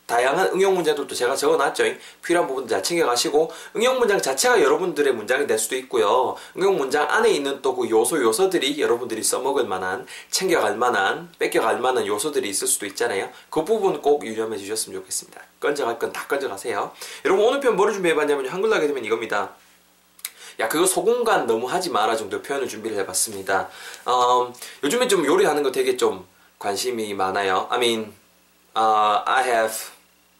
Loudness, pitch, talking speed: -22 LUFS, 390 Hz, 395 characters per minute